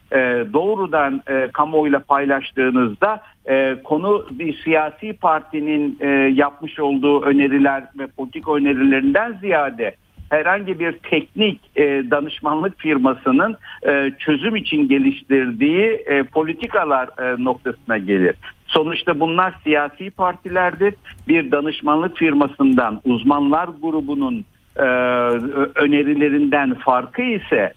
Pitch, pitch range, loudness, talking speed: 150 Hz, 135-185 Hz, -18 LUFS, 80 wpm